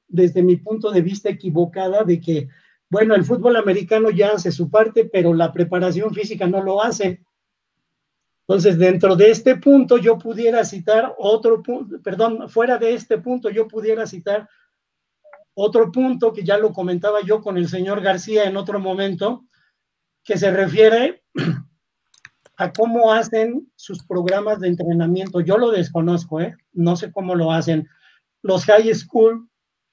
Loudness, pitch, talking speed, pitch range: -18 LUFS, 205 Hz, 155 wpm, 180-225 Hz